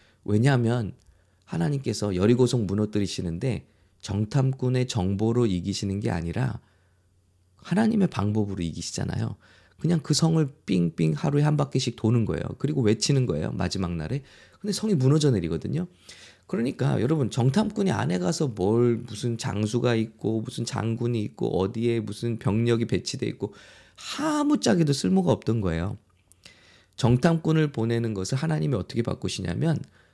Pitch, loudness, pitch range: 115 Hz, -26 LUFS, 100-145 Hz